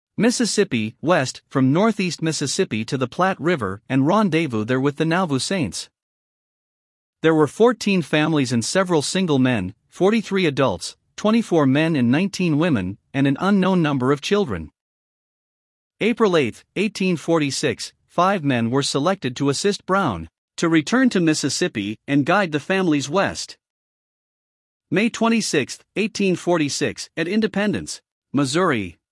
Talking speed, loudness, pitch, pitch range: 130 wpm, -20 LUFS, 160 Hz, 140-195 Hz